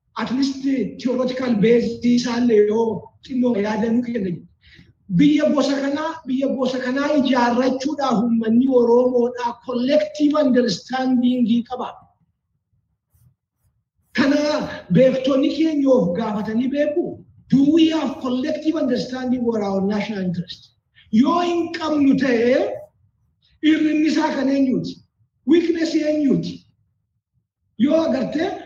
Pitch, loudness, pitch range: 255 Hz, -19 LUFS, 230-295 Hz